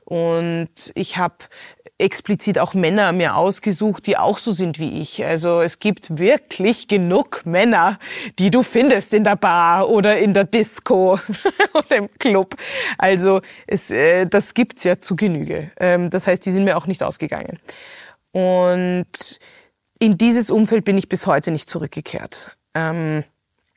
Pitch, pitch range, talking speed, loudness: 195 Hz, 175-220 Hz, 145 wpm, -18 LUFS